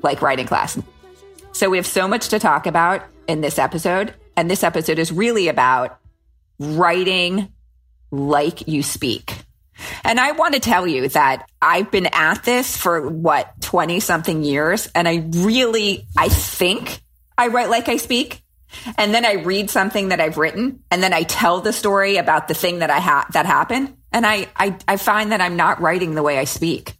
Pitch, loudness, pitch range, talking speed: 185 Hz, -18 LUFS, 160-220 Hz, 190 wpm